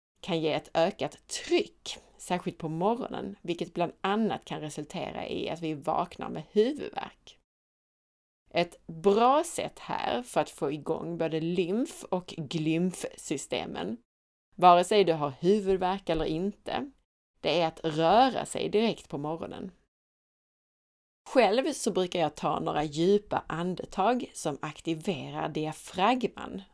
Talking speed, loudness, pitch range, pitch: 130 wpm, -29 LUFS, 160-205 Hz, 180 Hz